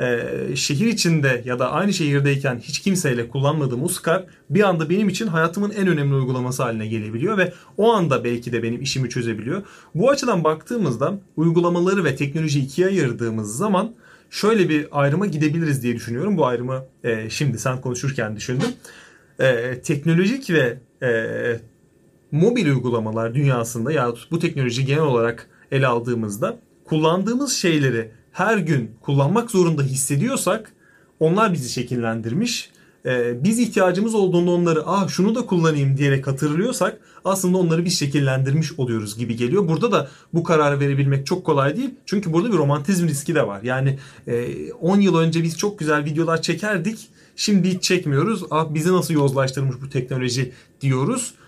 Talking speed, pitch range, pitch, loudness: 150 wpm, 130-180 Hz, 155 Hz, -21 LUFS